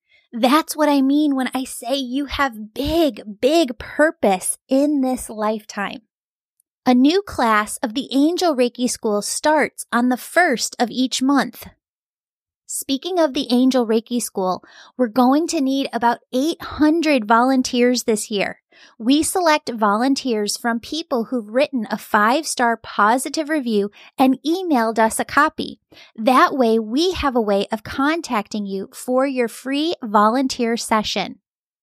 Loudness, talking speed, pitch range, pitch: -19 LUFS, 145 wpm, 230-290 Hz, 255 Hz